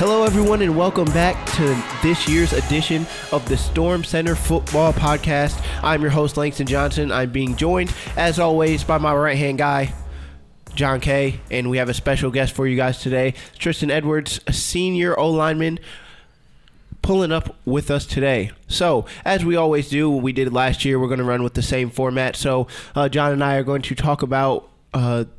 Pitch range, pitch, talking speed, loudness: 130-160 Hz, 145 Hz, 195 wpm, -20 LUFS